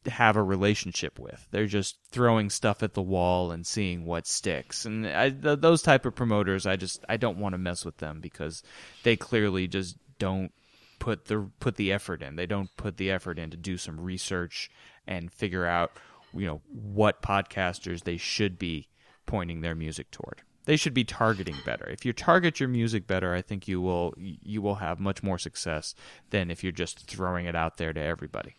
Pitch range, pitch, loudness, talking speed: 85-110 Hz, 95 Hz, -29 LUFS, 205 wpm